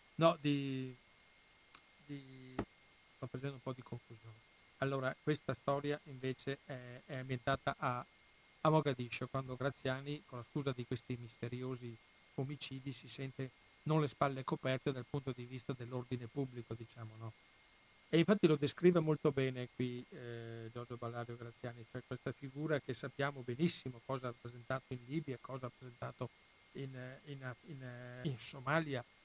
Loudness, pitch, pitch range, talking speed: -41 LUFS, 130 Hz, 125-140 Hz, 150 wpm